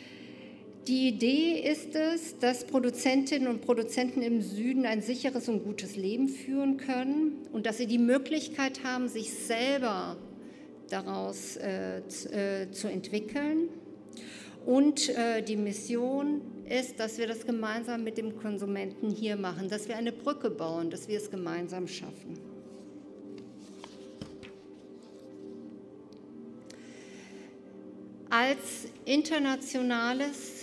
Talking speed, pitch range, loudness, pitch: 110 wpm, 180-260 Hz, -31 LUFS, 230 Hz